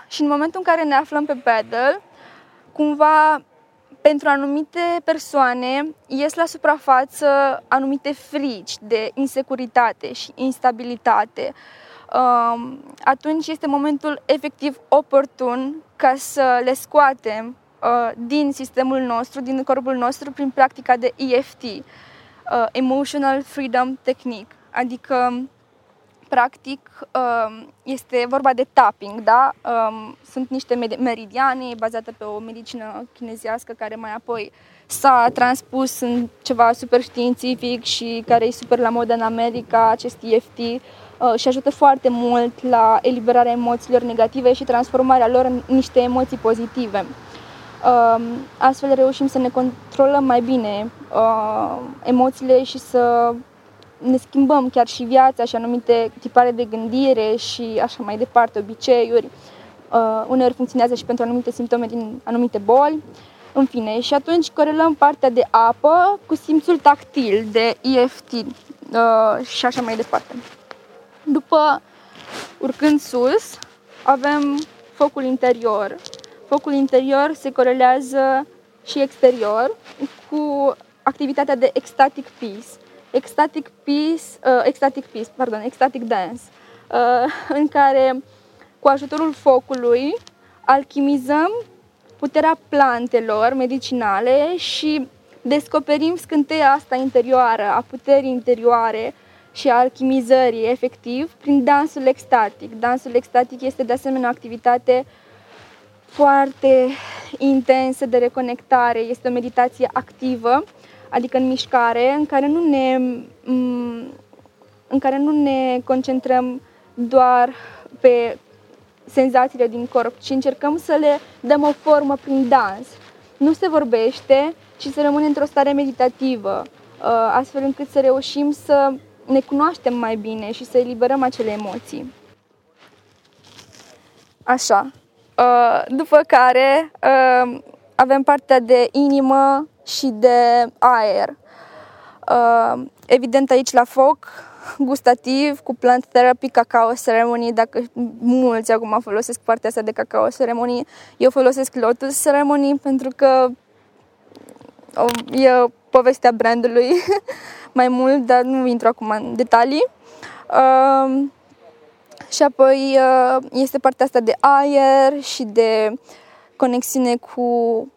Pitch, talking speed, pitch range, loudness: 260 Hz, 115 wpm, 240-275 Hz, -17 LUFS